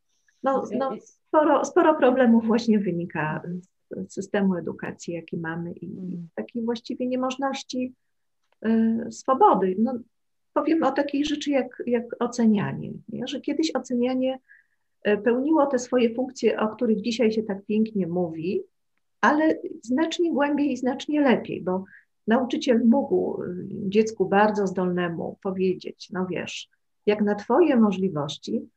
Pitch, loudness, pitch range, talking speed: 235 Hz, -24 LUFS, 195-270 Hz, 125 wpm